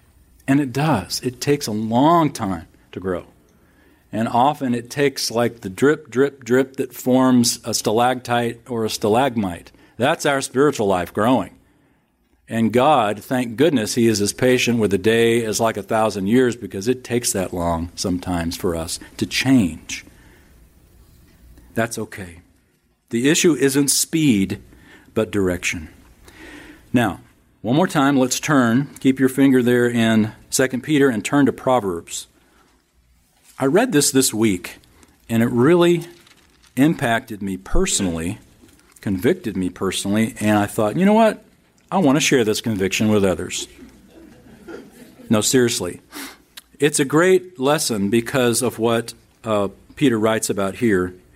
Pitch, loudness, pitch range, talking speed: 115 Hz, -19 LUFS, 100-135 Hz, 145 wpm